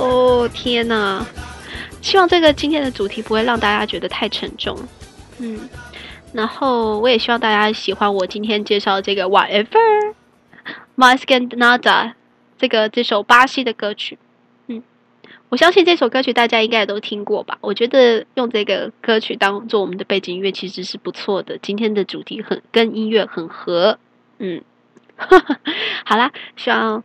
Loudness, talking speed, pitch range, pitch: -16 LUFS, 280 characters per minute, 205-250 Hz, 225 Hz